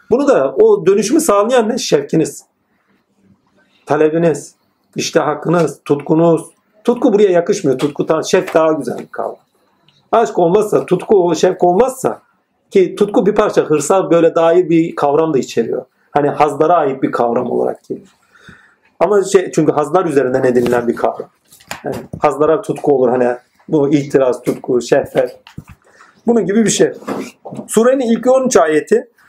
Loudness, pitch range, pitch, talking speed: -14 LUFS, 150-235 Hz, 170 Hz, 140 wpm